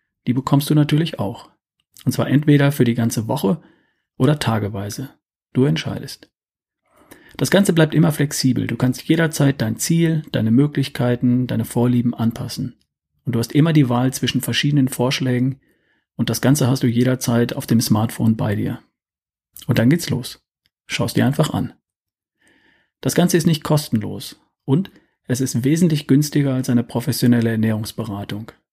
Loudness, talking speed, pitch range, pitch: -19 LUFS, 155 wpm, 115-145 Hz, 130 Hz